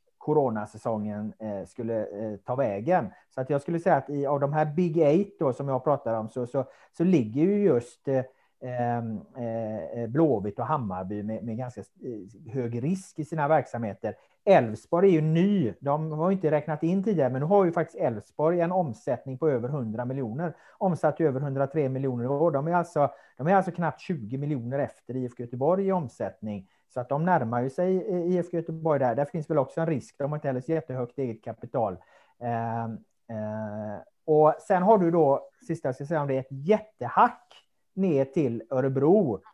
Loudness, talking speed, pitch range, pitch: -27 LUFS, 190 wpm, 120-165 Hz, 140 Hz